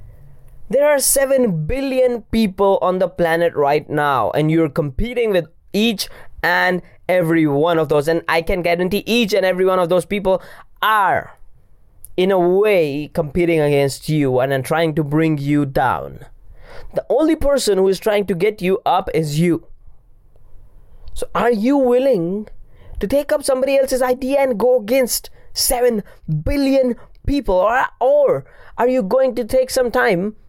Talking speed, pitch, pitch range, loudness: 155 wpm, 185 Hz, 155-245 Hz, -17 LUFS